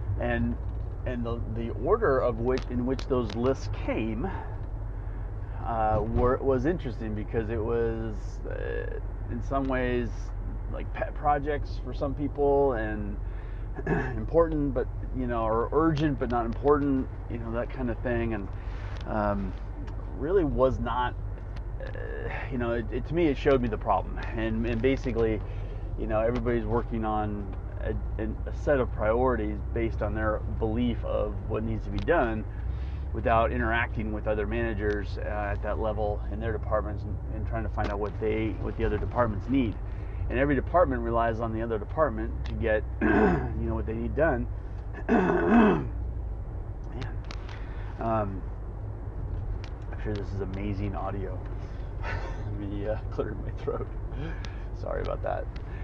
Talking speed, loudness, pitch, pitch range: 155 wpm, -30 LUFS, 110 Hz, 100-115 Hz